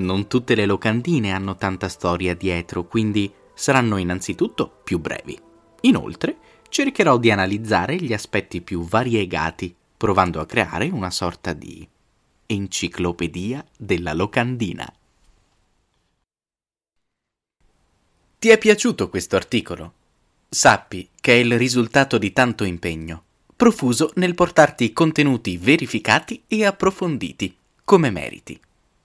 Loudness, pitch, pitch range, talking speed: -20 LUFS, 110 Hz, 90-140 Hz, 105 wpm